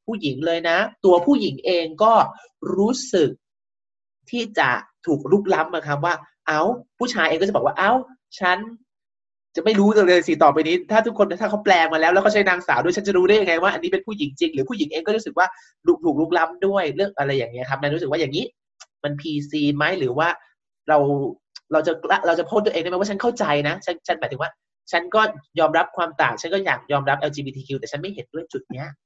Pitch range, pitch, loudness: 150-210 Hz, 170 Hz, -20 LUFS